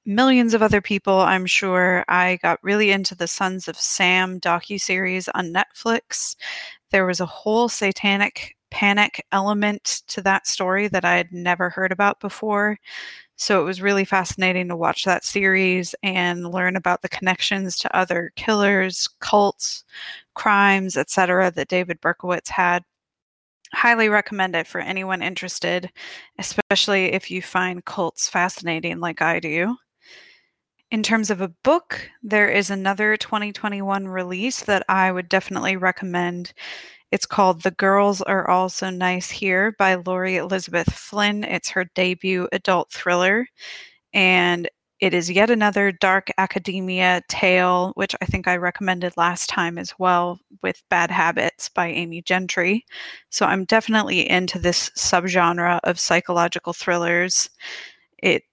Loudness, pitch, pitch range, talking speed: -20 LUFS, 185 Hz, 180-200 Hz, 145 wpm